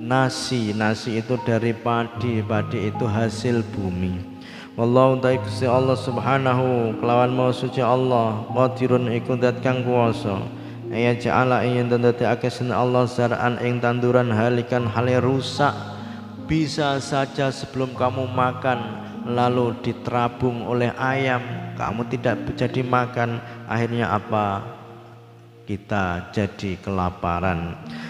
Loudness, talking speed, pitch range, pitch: -22 LUFS, 115 wpm, 115-125 Hz, 120 Hz